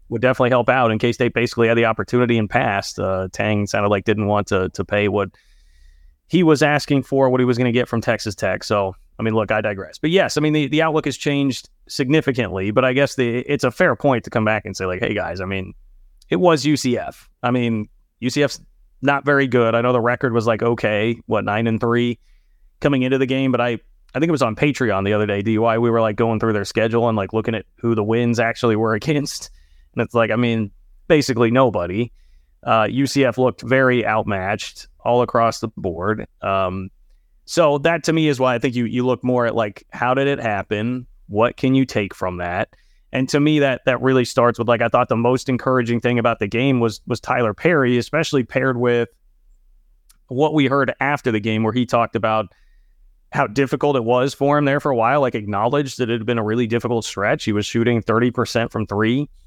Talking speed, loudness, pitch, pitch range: 225 wpm, -19 LUFS, 120 Hz, 110-130 Hz